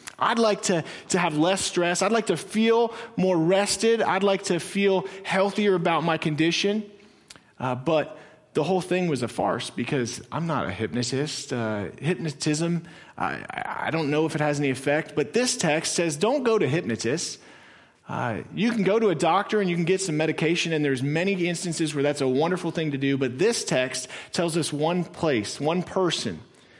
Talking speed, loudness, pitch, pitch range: 195 wpm, -25 LUFS, 170 Hz, 150-195 Hz